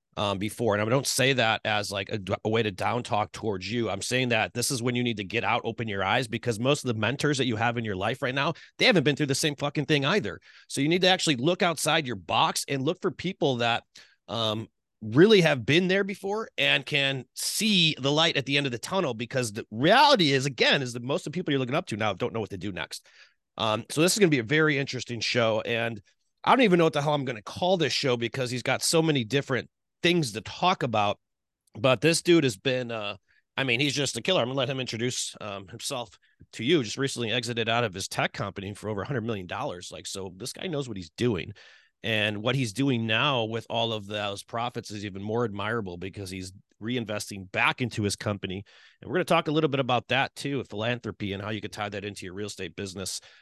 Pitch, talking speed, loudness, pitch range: 120 Hz, 255 wpm, -26 LUFS, 105-145 Hz